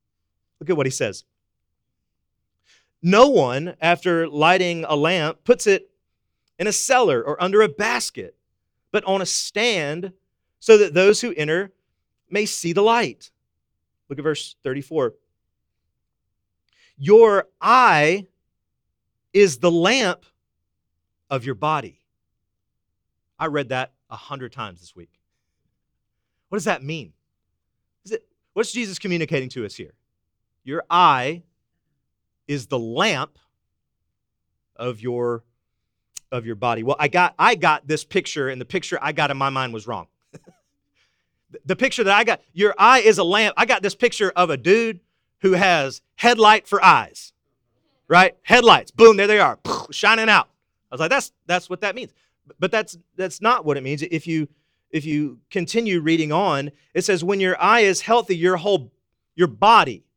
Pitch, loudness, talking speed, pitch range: 170 Hz, -18 LUFS, 155 wpm, 135-205 Hz